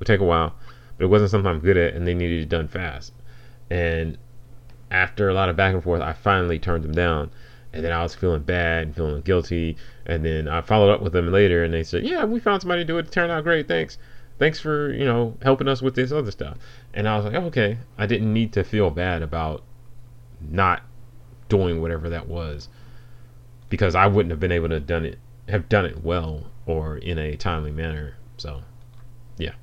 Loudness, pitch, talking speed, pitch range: -22 LUFS, 100 Hz, 225 wpm, 85-120 Hz